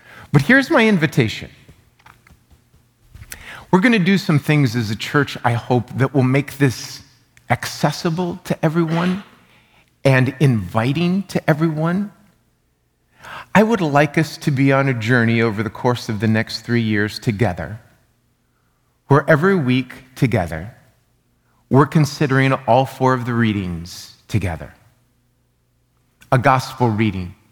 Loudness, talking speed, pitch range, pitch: -18 LUFS, 130 wpm, 115-155 Hz, 130 Hz